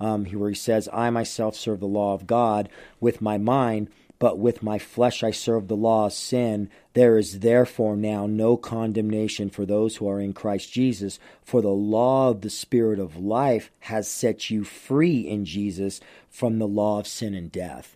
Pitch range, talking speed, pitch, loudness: 100-115 Hz, 195 wpm, 110 Hz, -24 LUFS